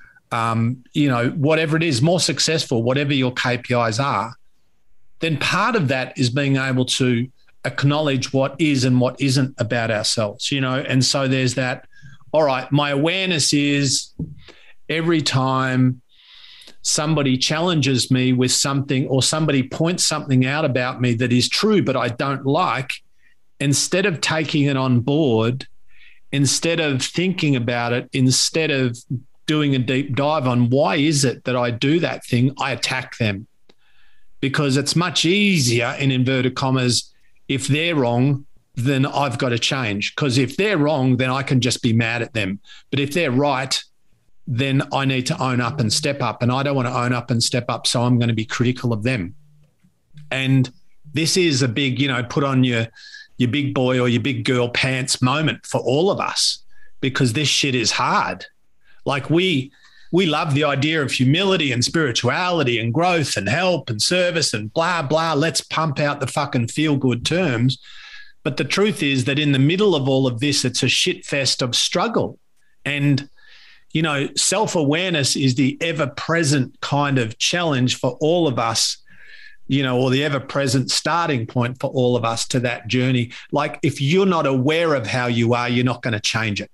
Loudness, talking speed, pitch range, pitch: -19 LUFS, 180 wpm, 125-155 Hz, 135 Hz